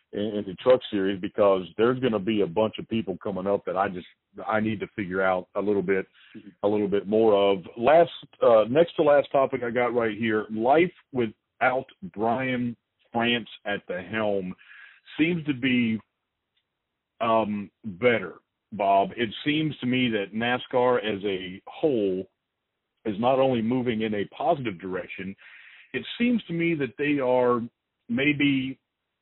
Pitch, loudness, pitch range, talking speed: 115 Hz, -25 LUFS, 100-130 Hz, 160 wpm